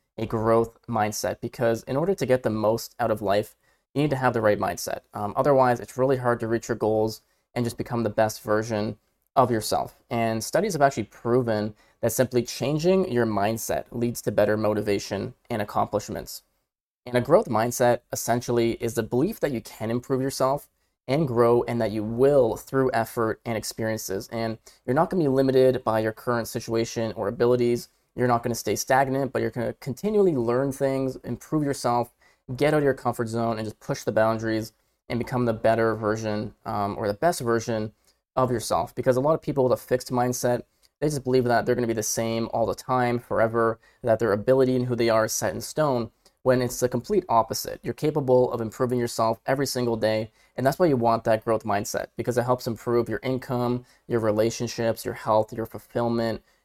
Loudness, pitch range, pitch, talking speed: -25 LUFS, 110-130 Hz, 120 Hz, 200 wpm